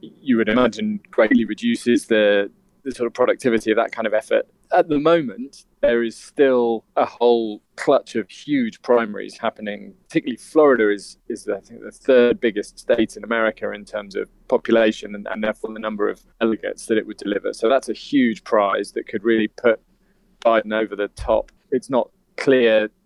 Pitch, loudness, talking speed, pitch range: 115 Hz, -20 LUFS, 185 wpm, 110-150 Hz